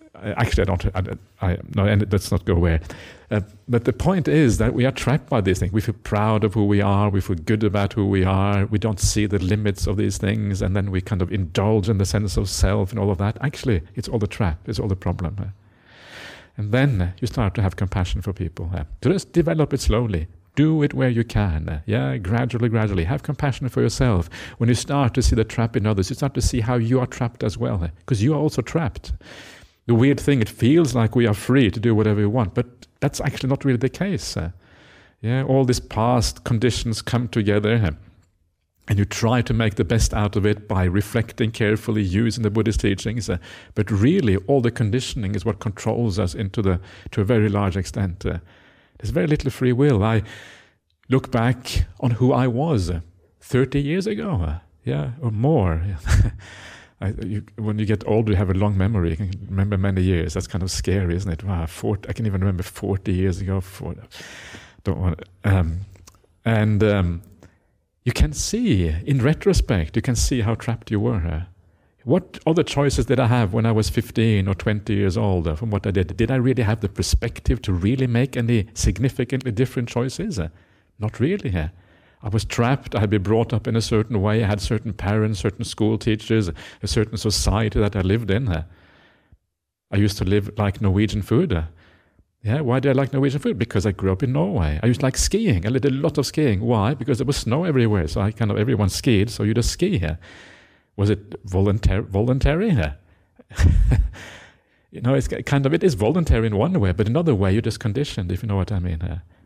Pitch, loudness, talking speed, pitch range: 105 Hz, -21 LUFS, 215 wpm, 95-120 Hz